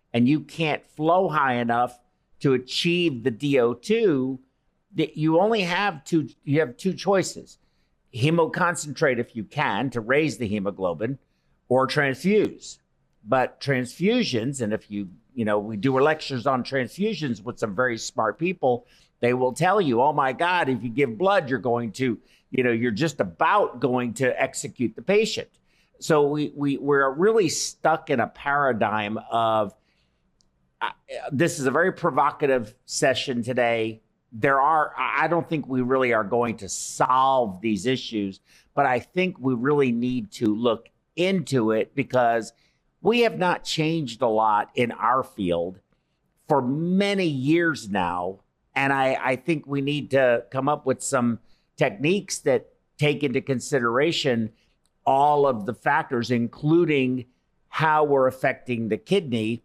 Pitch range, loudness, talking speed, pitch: 120-155 Hz, -24 LUFS, 150 wpm, 135 Hz